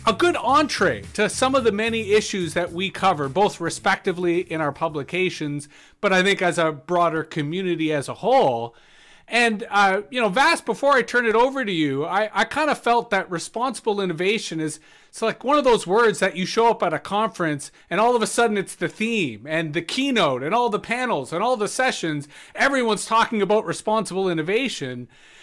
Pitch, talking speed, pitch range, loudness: 200 Hz, 200 wpm, 170-230 Hz, -21 LUFS